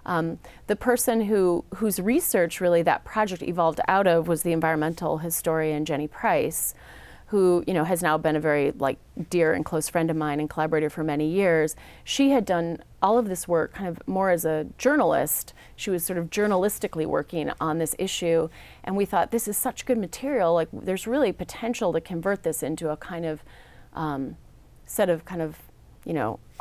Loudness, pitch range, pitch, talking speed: -25 LUFS, 155-195 Hz, 170 Hz, 195 wpm